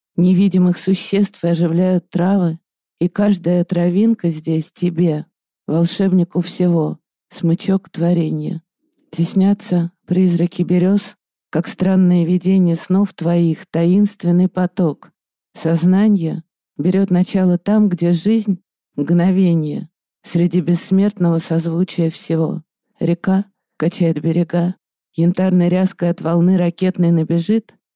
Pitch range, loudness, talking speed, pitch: 170-190 Hz, -17 LUFS, 95 wpm, 180 Hz